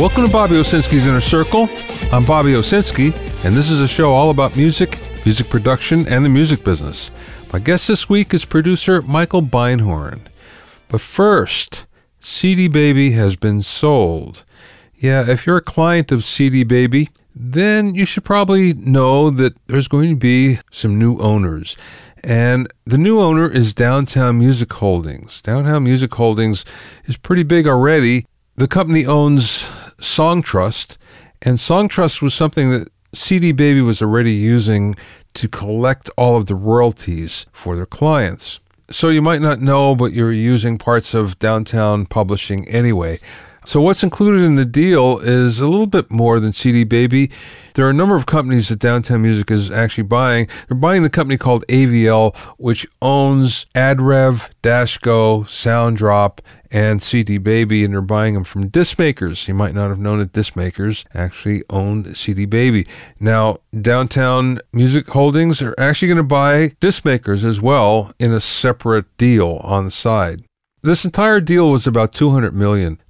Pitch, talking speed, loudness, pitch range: 125 Hz, 160 wpm, -14 LUFS, 110-150 Hz